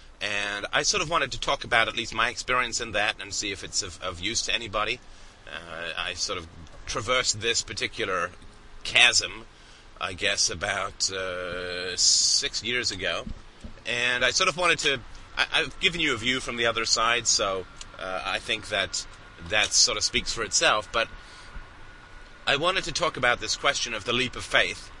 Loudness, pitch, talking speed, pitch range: -25 LUFS, 115 Hz, 185 wpm, 100-125 Hz